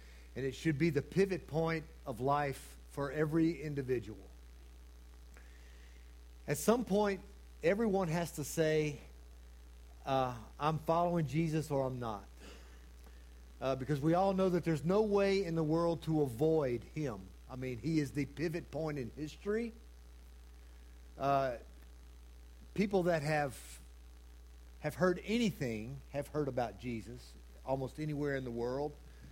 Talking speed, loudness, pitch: 135 wpm, -36 LUFS, 135 Hz